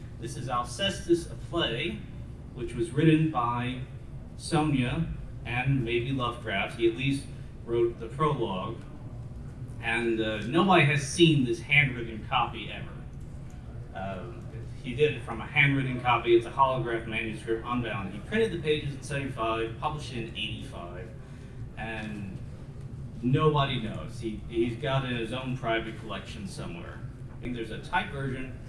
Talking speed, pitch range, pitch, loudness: 145 wpm, 115-135 Hz, 125 Hz, -29 LUFS